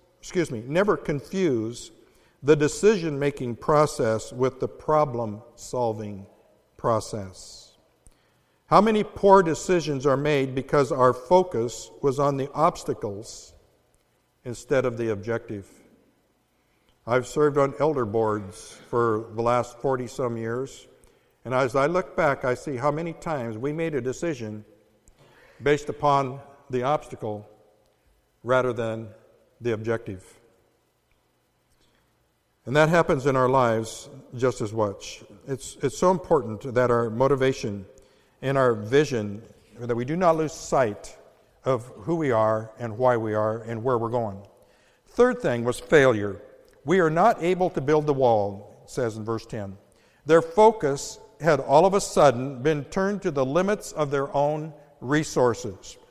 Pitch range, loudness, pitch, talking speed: 115-150 Hz, -24 LUFS, 130 Hz, 140 wpm